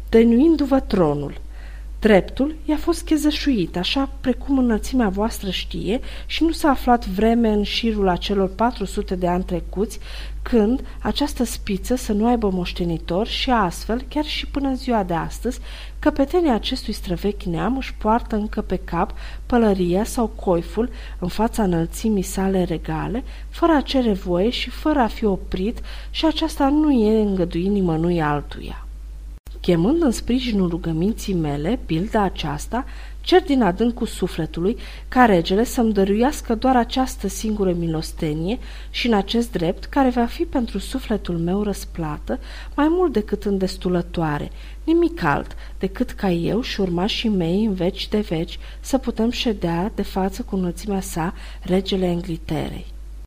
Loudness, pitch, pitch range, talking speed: -21 LUFS, 210 Hz, 180-245 Hz, 145 wpm